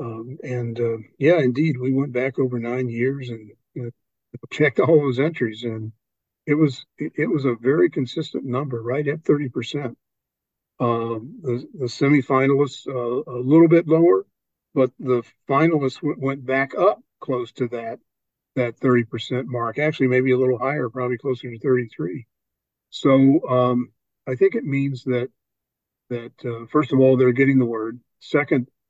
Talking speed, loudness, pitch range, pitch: 165 wpm, -21 LUFS, 120-140 Hz, 130 Hz